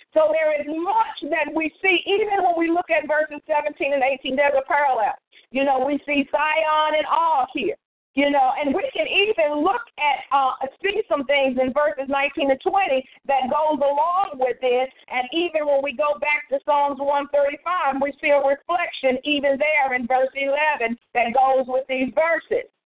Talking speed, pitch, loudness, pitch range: 195 wpm, 295 Hz, -21 LUFS, 275-320 Hz